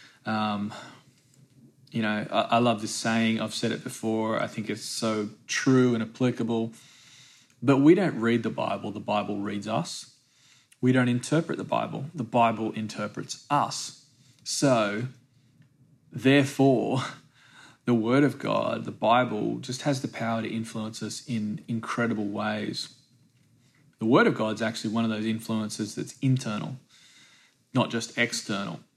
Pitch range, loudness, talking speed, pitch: 110-130 Hz, -27 LUFS, 145 wpm, 120 Hz